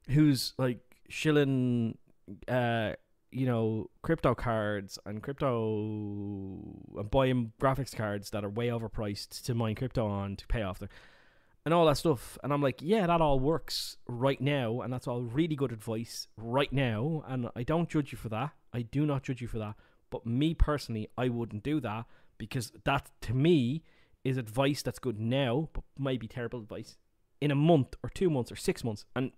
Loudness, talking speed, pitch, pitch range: -32 LUFS, 190 wpm, 125 Hz, 110-140 Hz